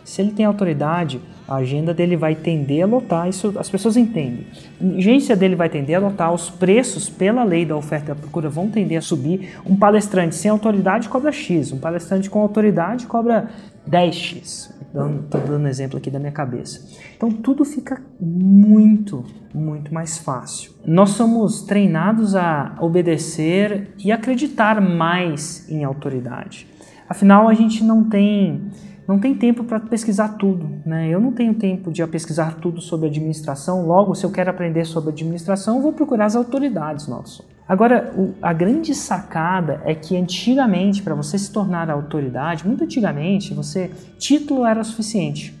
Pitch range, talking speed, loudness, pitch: 165-215 Hz, 165 wpm, -18 LUFS, 185 Hz